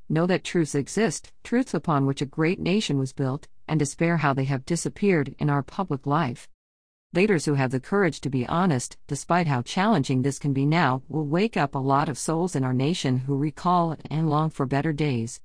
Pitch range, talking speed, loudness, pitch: 135-170 Hz, 210 wpm, -25 LUFS, 145 Hz